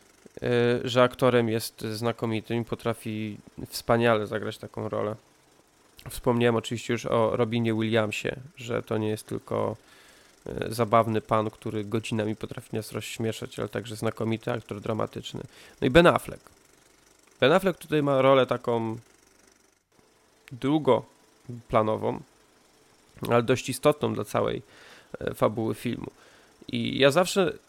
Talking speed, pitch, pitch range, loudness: 120 wpm, 115 Hz, 110-125 Hz, -27 LUFS